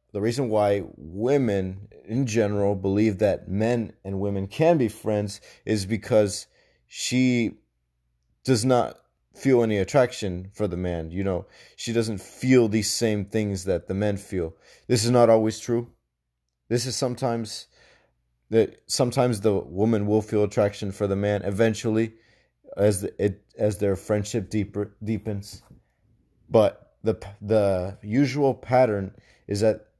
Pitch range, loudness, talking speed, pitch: 100-115 Hz, -24 LUFS, 140 wpm, 105 Hz